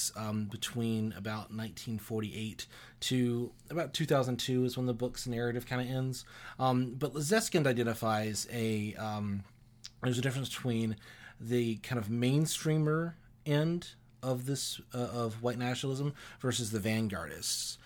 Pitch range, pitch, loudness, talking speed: 110-130 Hz, 120 Hz, -34 LUFS, 130 wpm